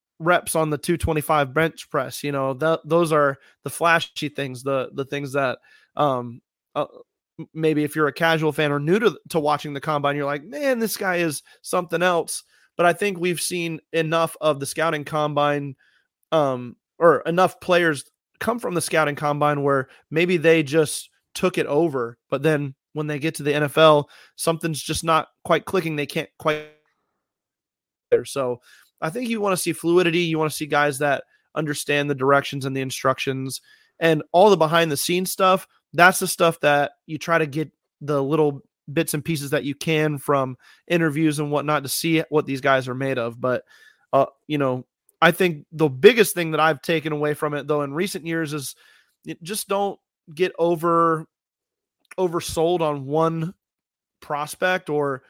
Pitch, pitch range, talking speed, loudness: 155 Hz, 145-170 Hz, 180 wpm, -22 LUFS